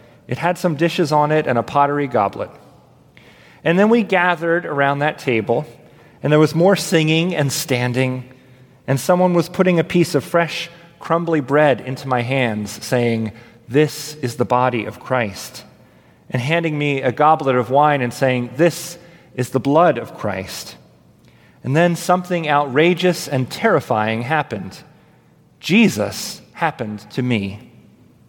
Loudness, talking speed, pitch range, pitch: -18 LUFS, 150 wpm, 125-165 Hz, 145 Hz